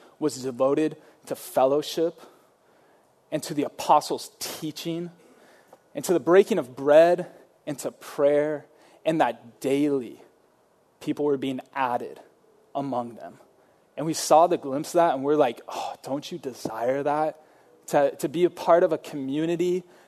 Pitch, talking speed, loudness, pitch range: 150 Hz, 150 wpm, -25 LUFS, 140-170 Hz